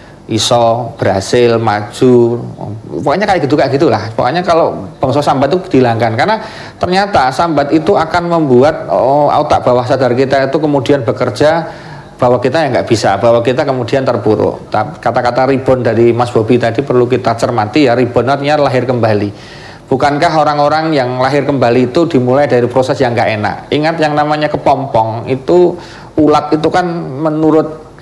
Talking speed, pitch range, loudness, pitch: 155 wpm, 120-155 Hz, -11 LUFS, 130 Hz